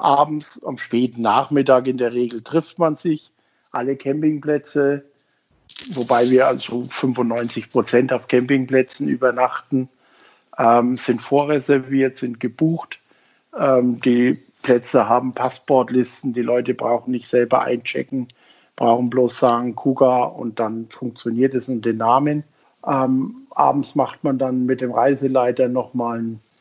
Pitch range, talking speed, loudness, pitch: 120-135 Hz, 130 wpm, -19 LUFS, 130 Hz